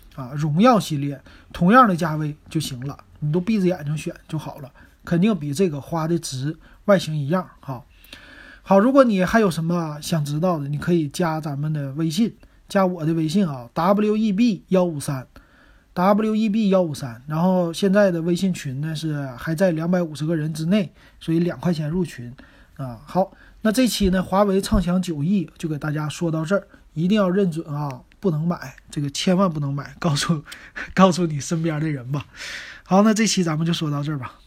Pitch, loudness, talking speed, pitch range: 170 Hz, -21 LUFS, 290 characters per minute, 150-190 Hz